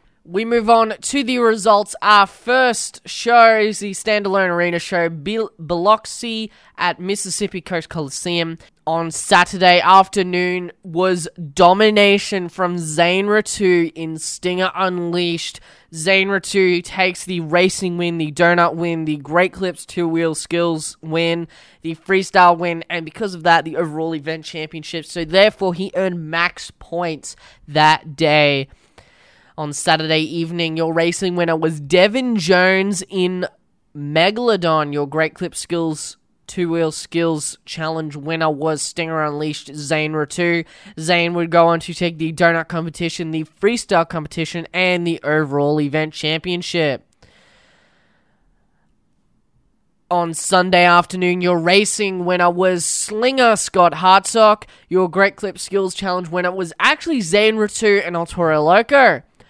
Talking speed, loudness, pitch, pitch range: 130 wpm, -17 LUFS, 175 Hz, 165-190 Hz